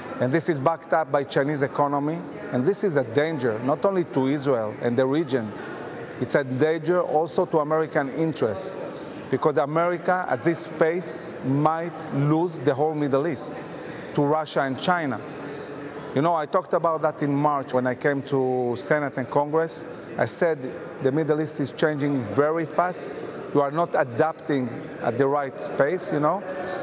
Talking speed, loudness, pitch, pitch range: 170 wpm, -24 LUFS, 150 Hz, 140-165 Hz